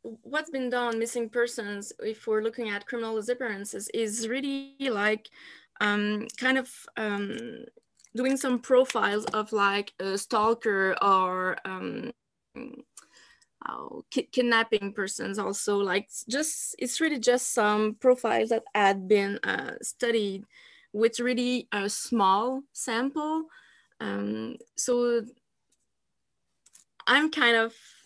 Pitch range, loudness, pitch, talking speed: 205-250 Hz, -27 LUFS, 230 Hz, 115 wpm